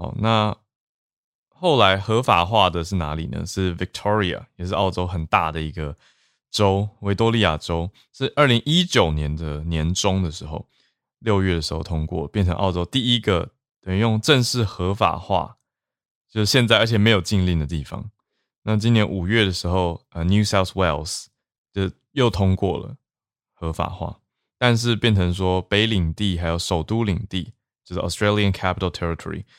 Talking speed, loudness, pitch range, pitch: 320 characters per minute, -21 LUFS, 85-110 Hz, 95 Hz